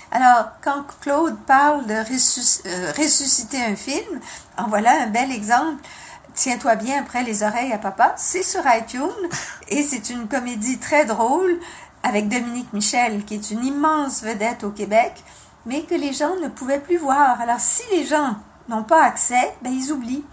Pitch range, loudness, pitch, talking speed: 235-300 Hz, -19 LUFS, 255 Hz, 175 wpm